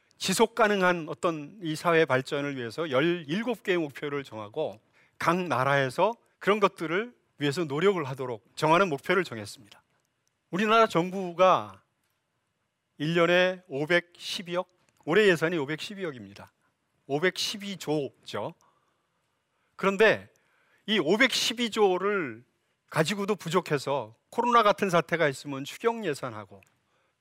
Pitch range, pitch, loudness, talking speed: 140-195 Hz, 170 Hz, -27 LUFS, 235 characters per minute